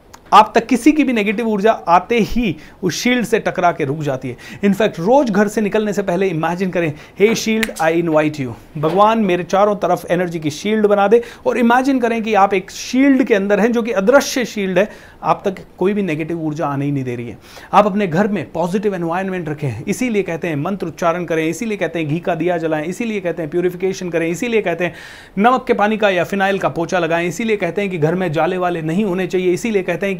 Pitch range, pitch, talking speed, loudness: 165-215 Hz, 190 Hz, 235 wpm, -17 LUFS